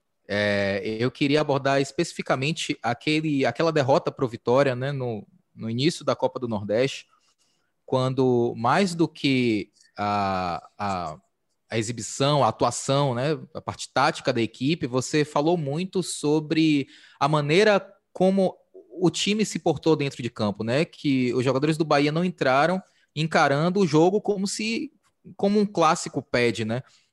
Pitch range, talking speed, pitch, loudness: 125-170 Hz, 150 wpm, 150 Hz, -24 LUFS